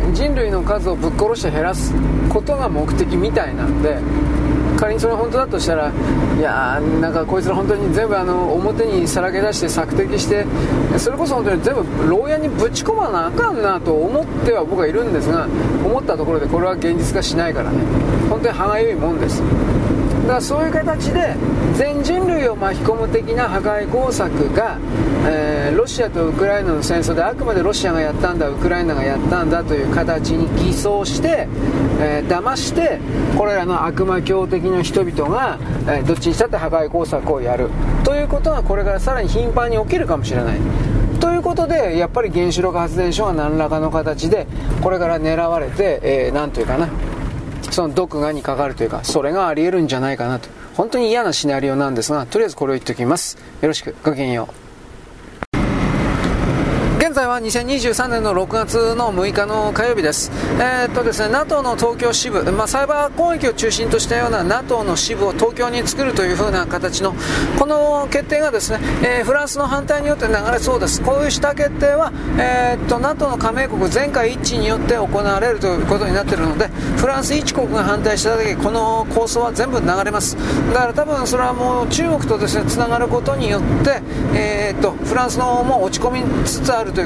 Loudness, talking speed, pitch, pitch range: -18 LUFS, 400 characters per minute, 215 Hz, 160-260 Hz